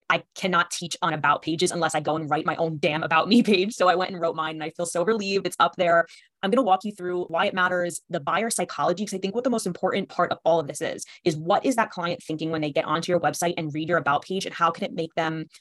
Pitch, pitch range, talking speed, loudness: 175 Hz, 160-190 Hz, 305 wpm, -24 LUFS